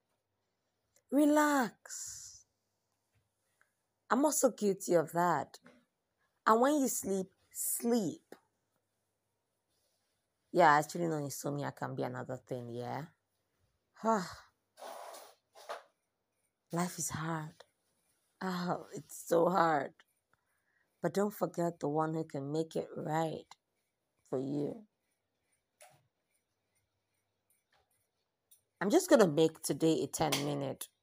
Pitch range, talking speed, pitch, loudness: 135-195 Hz, 90 wpm, 160 Hz, -33 LUFS